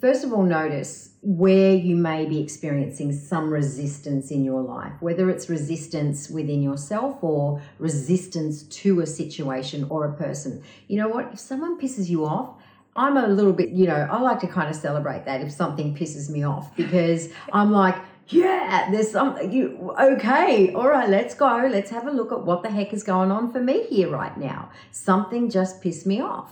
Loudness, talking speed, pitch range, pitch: -23 LUFS, 195 wpm, 150-210 Hz, 180 Hz